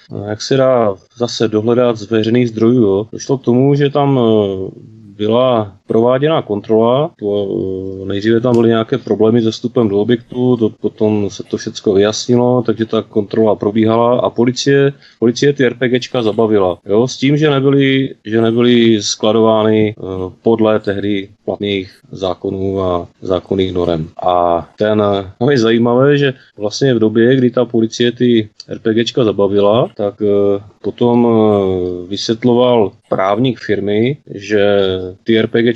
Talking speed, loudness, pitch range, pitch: 140 wpm, -14 LUFS, 100-120 Hz, 110 Hz